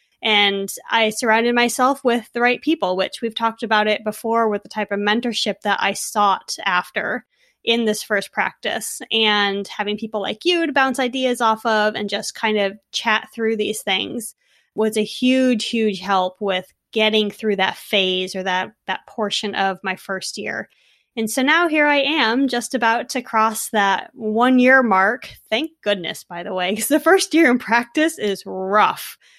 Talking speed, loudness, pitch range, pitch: 185 wpm, -19 LUFS, 205-245 Hz, 220 Hz